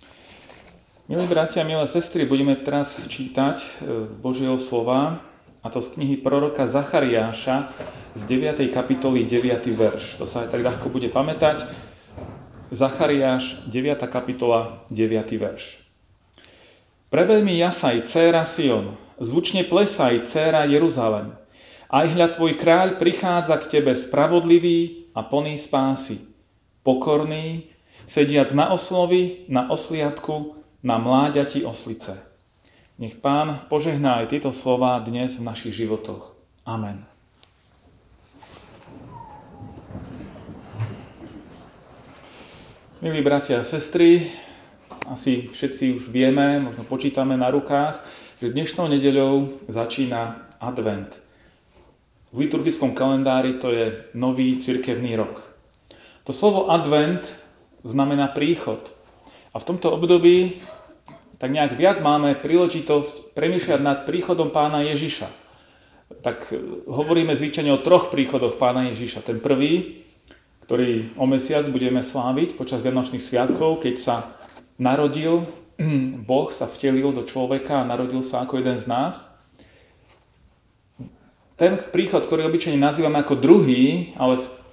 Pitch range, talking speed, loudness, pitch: 120-150 Hz, 110 wpm, -21 LUFS, 135 Hz